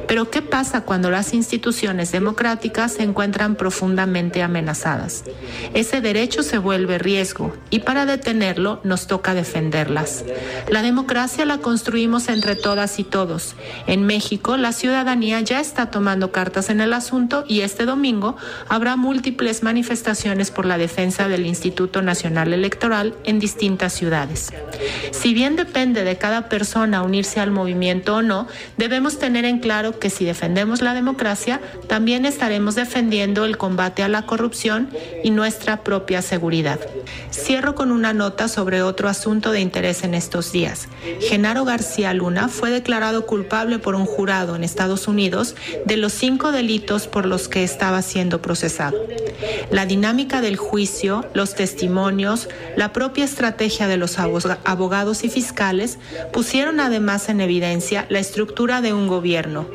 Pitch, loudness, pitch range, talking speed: 210 Hz, -20 LUFS, 185-235 Hz, 145 wpm